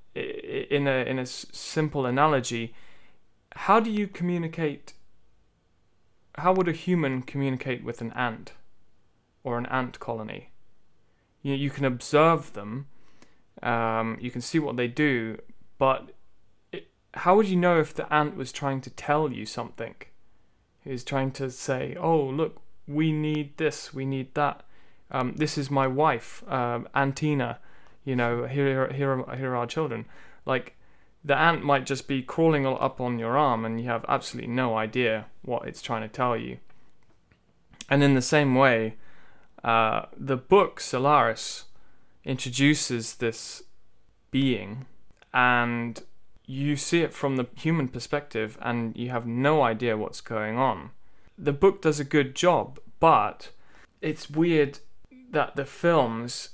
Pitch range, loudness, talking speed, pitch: 120-150 Hz, -26 LUFS, 150 wpm, 135 Hz